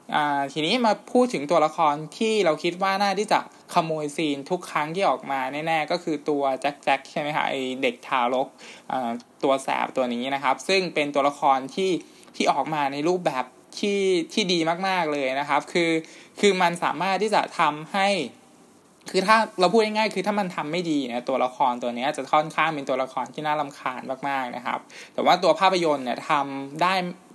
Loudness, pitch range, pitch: -24 LUFS, 140-190 Hz, 155 Hz